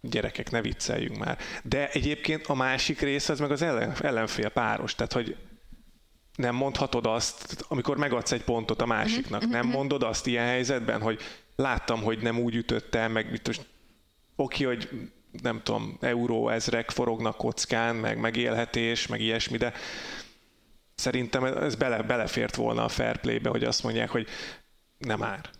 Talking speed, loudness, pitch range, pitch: 155 wpm, -29 LUFS, 115-135 Hz, 120 Hz